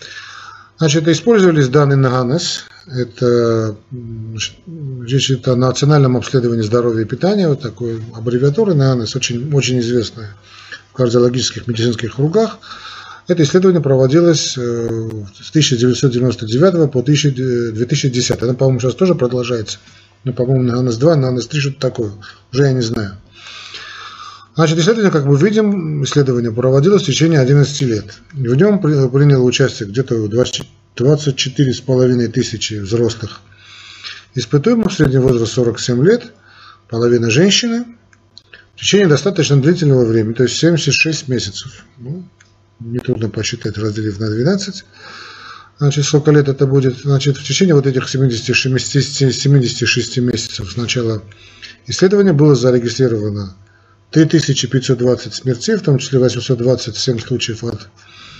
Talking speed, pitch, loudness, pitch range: 120 wpm, 130 Hz, -14 LUFS, 115-145 Hz